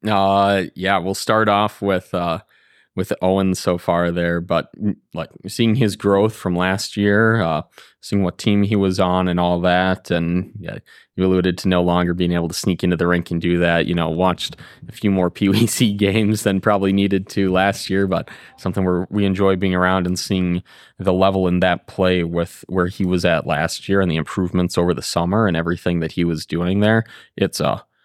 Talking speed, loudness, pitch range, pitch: 210 wpm, -19 LUFS, 90-100 Hz, 95 Hz